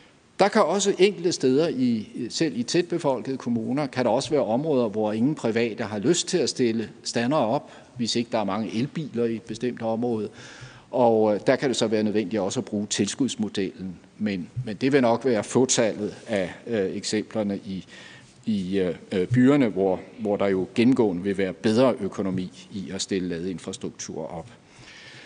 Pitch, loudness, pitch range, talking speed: 115 Hz, -25 LUFS, 105-130 Hz, 180 wpm